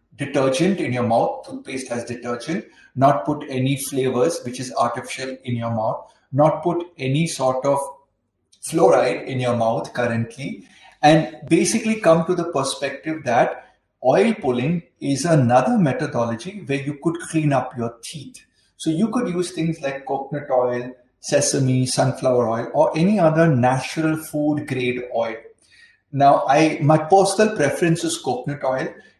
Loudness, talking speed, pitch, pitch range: -20 LUFS, 145 wpm, 140 Hz, 125-165 Hz